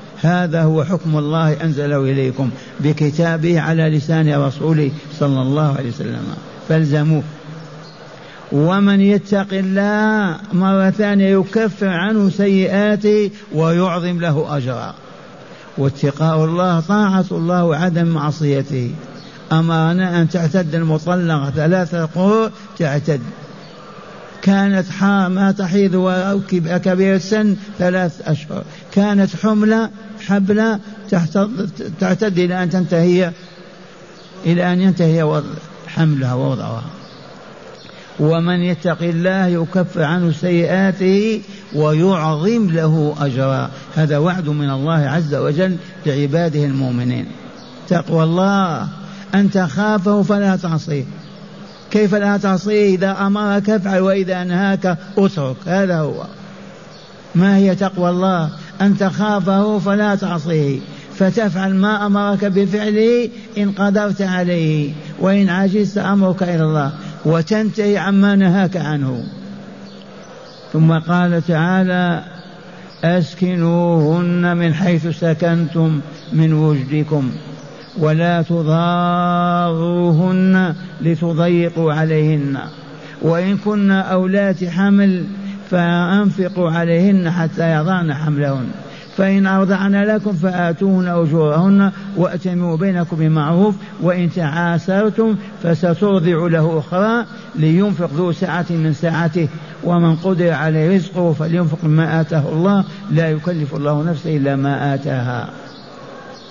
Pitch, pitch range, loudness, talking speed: 175 Hz, 160-195 Hz, -16 LUFS, 95 wpm